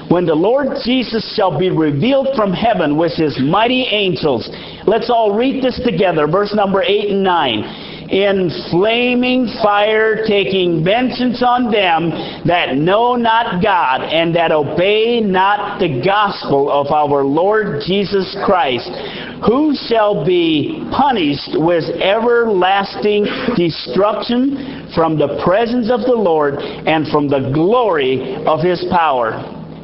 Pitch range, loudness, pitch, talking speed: 170-240 Hz, -14 LUFS, 205 Hz, 130 wpm